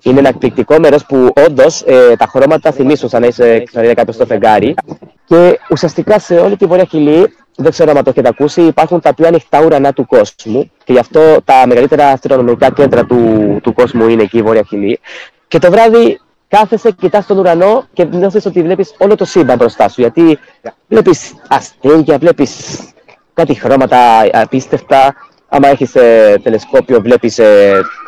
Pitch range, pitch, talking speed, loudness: 125-200 Hz, 155 Hz, 170 wpm, -8 LUFS